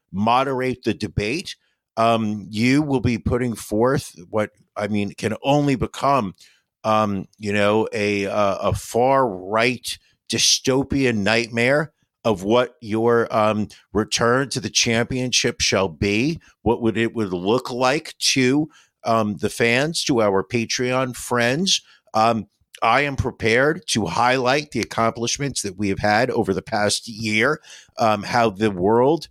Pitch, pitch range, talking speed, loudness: 115 Hz, 105-125 Hz, 140 wpm, -20 LUFS